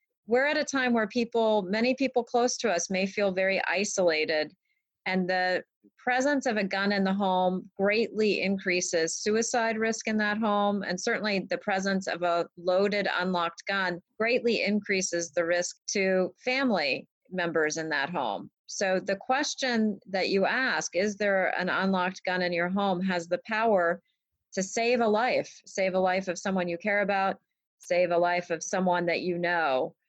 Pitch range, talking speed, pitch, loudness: 180-220 Hz, 175 wpm, 195 Hz, -27 LUFS